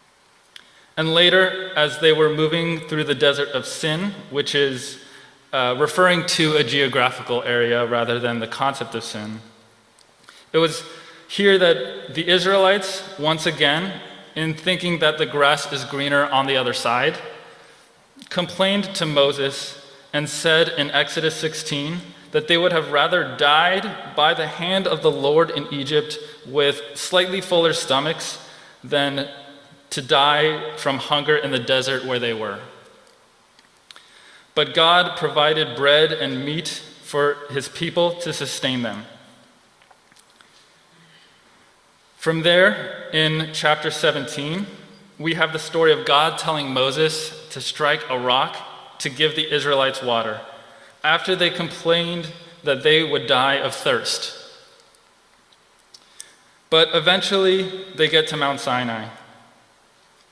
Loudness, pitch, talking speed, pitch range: -19 LUFS, 155 Hz, 130 wpm, 140-170 Hz